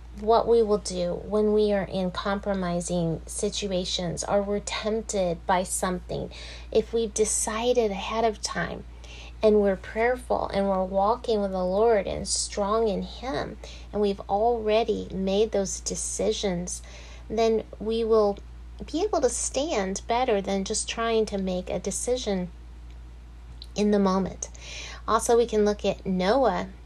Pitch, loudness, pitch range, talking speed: 200 Hz, -26 LUFS, 180-220 Hz, 145 wpm